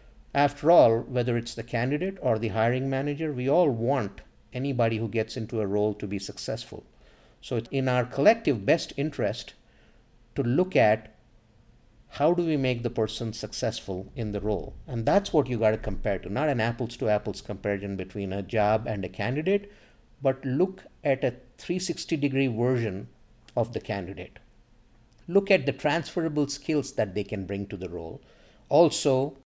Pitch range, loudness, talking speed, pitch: 110-140 Hz, -27 LUFS, 175 wpm, 115 Hz